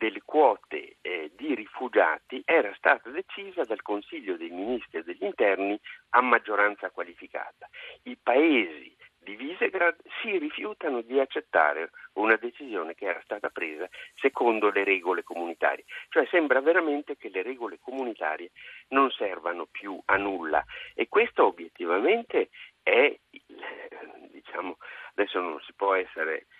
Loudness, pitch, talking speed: -27 LUFS, 360 Hz, 135 wpm